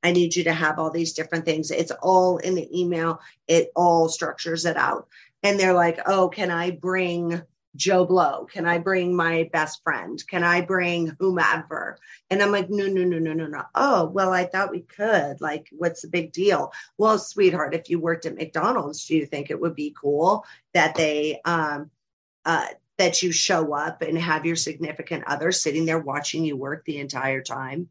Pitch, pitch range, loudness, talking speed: 170 Hz, 155-180 Hz, -23 LUFS, 200 wpm